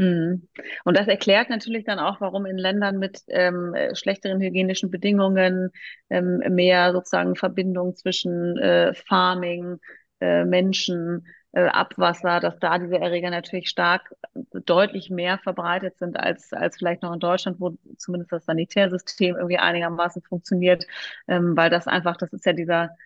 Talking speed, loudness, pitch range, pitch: 145 wpm, -22 LUFS, 175-190 Hz, 180 Hz